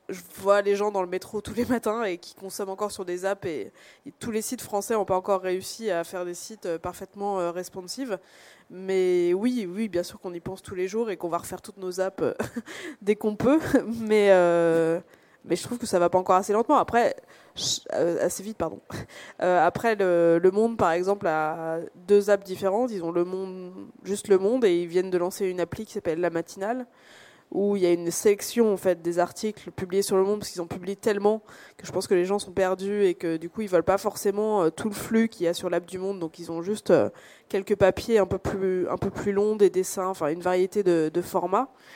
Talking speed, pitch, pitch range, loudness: 235 wpm, 190 Hz, 180-215 Hz, -26 LUFS